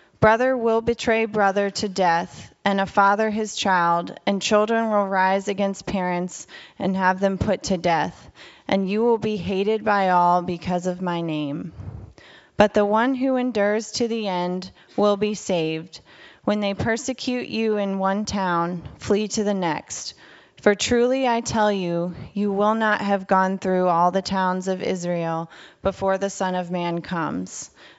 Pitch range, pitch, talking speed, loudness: 180-215 Hz, 195 Hz, 165 wpm, -22 LUFS